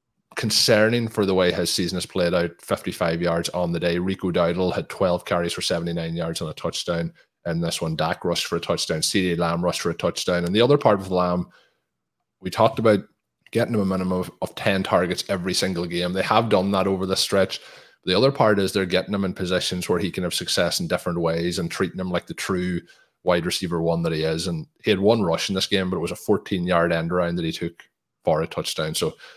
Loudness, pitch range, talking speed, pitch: -23 LUFS, 85-95 Hz, 235 wpm, 90 Hz